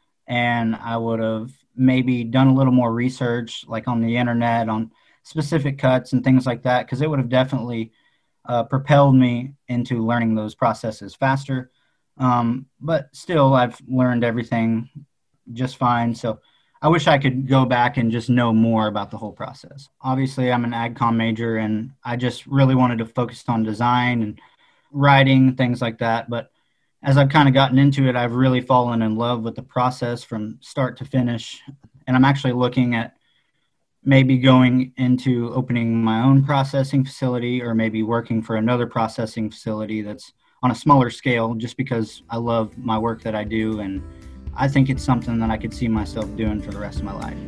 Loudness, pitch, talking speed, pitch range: -20 LUFS, 120 Hz, 185 wpm, 115-130 Hz